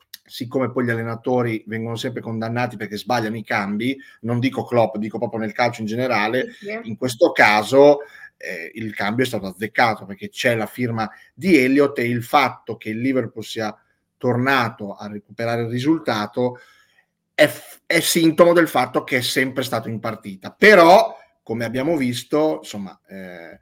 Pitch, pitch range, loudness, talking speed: 120 Hz, 110-130 Hz, -19 LUFS, 165 wpm